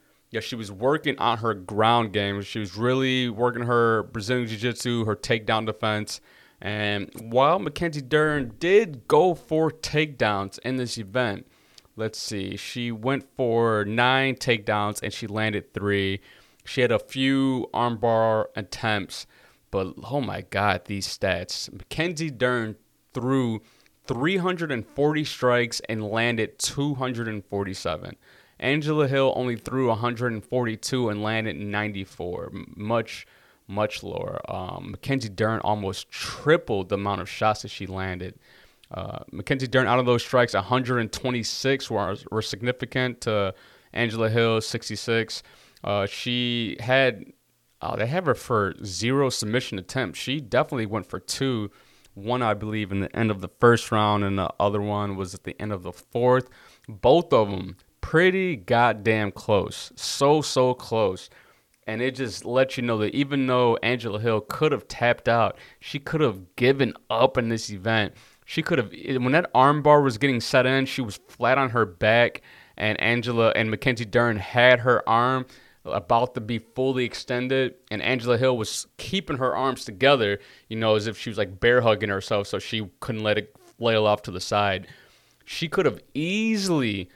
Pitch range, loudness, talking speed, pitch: 105-130 Hz, -24 LUFS, 160 wpm, 115 Hz